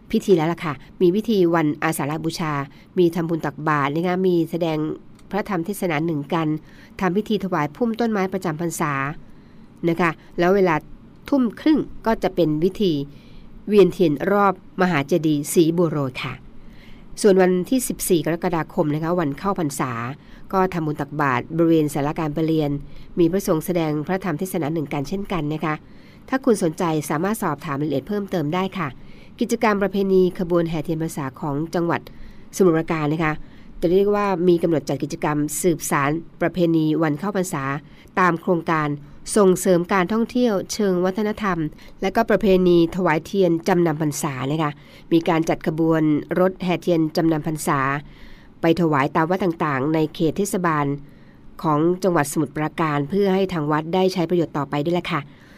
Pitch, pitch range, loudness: 170 Hz, 155-185 Hz, -21 LUFS